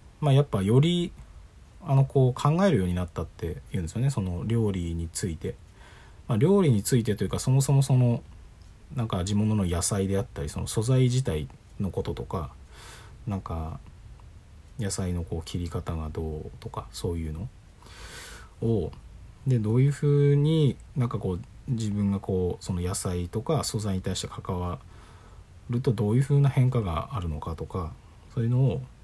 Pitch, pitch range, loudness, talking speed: 100 Hz, 90-125 Hz, -27 LUFS, 320 characters per minute